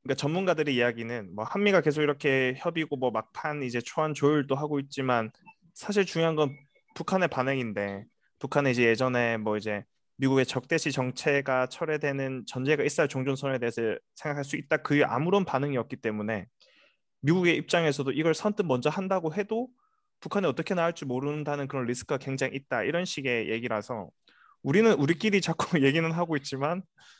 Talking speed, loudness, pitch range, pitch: 395 characters per minute, -28 LUFS, 130-165 Hz, 140 Hz